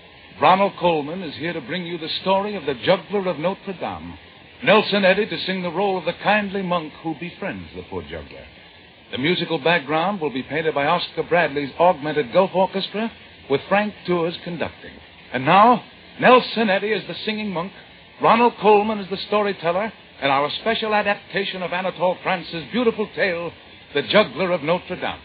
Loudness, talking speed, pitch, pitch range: -21 LUFS, 175 wpm, 180 Hz, 160-200 Hz